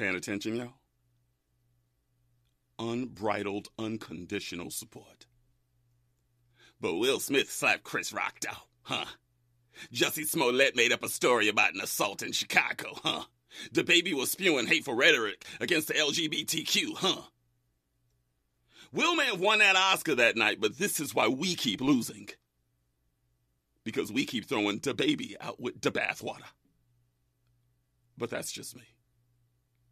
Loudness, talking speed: -28 LUFS, 130 wpm